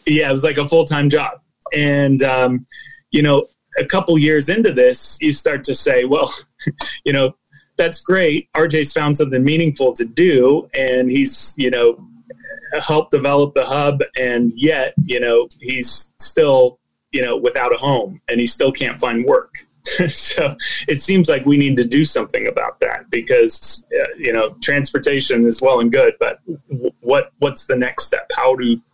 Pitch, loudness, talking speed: 150 Hz, -16 LUFS, 180 wpm